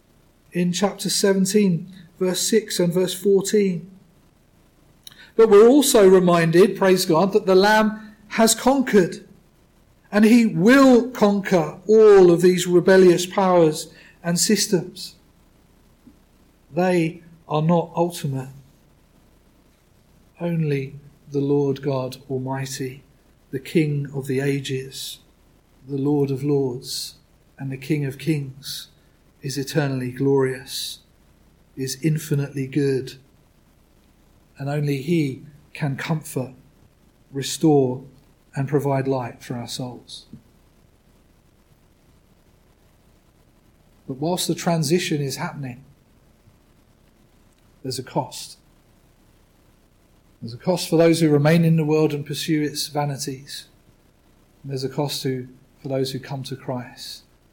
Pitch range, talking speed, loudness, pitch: 135-180 Hz, 110 wpm, -20 LUFS, 150 Hz